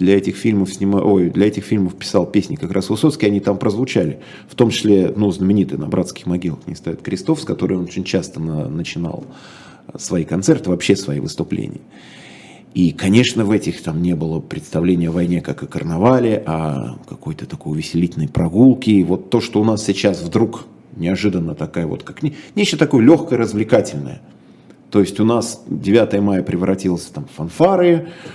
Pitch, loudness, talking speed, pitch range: 100 Hz, -17 LUFS, 175 wpm, 85-110 Hz